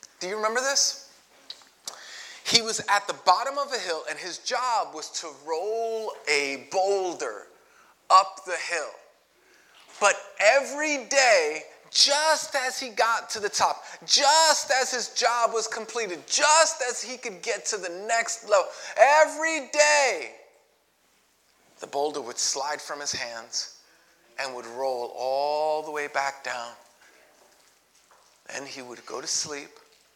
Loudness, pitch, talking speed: -24 LUFS, 235 Hz, 140 wpm